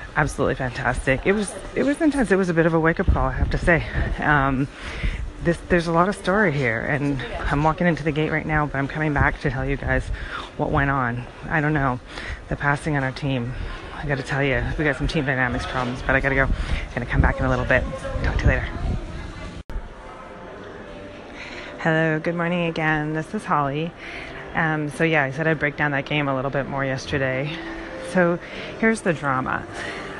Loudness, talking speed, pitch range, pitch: -23 LUFS, 210 wpm, 130-160 Hz, 145 Hz